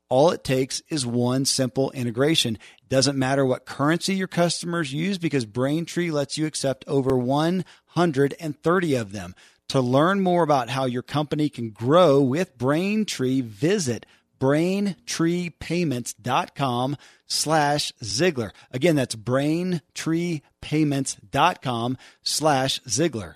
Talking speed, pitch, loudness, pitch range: 115 wpm, 140 Hz, -23 LUFS, 130-165 Hz